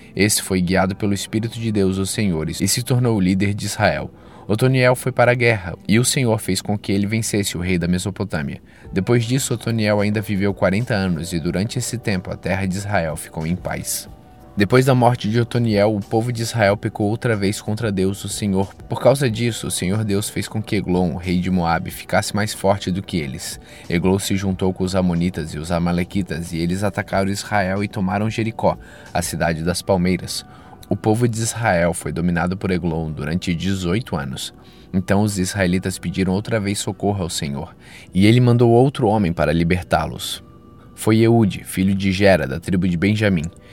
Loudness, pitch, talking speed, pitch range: -20 LUFS, 100 Hz, 195 wpm, 90-110 Hz